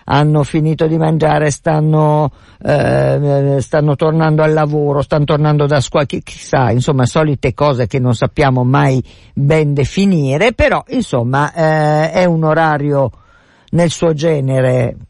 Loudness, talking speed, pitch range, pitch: -13 LUFS, 130 wpm, 135-155 Hz, 150 Hz